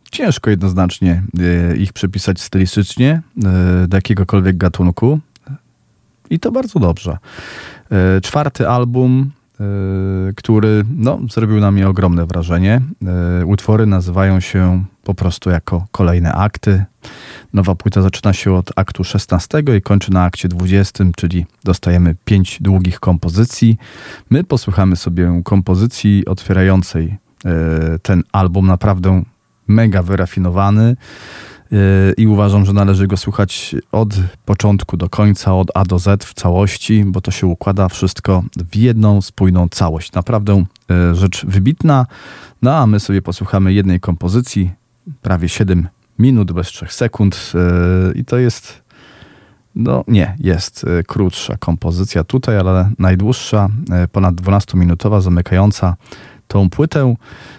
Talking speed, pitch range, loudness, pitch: 120 wpm, 90-110 Hz, -14 LUFS, 95 Hz